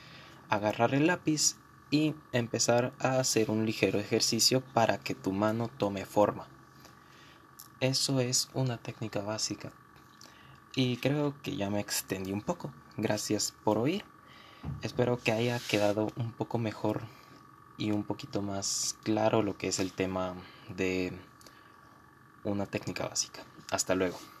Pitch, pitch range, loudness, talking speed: 110 Hz, 105-125 Hz, -31 LUFS, 135 wpm